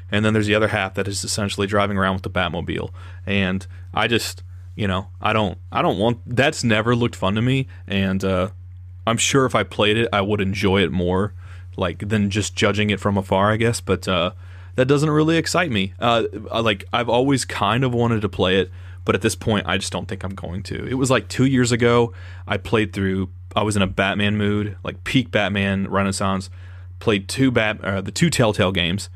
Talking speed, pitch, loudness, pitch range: 220 wpm, 100 Hz, -20 LUFS, 95-110 Hz